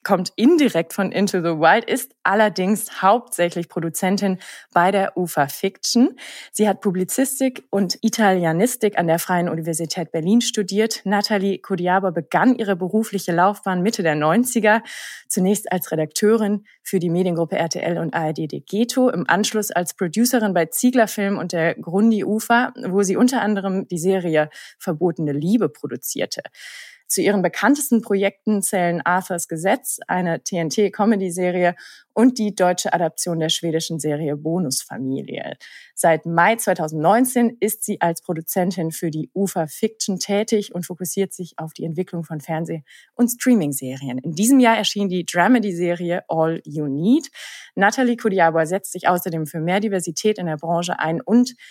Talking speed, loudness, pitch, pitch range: 150 wpm, -20 LUFS, 190 Hz, 170-215 Hz